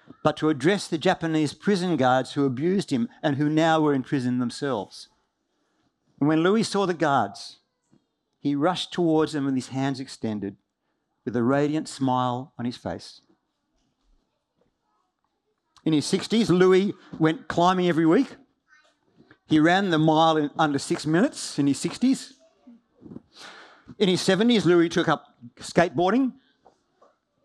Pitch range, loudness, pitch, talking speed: 140-195 Hz, -23 LUFS, 160 Hz, 140 wpm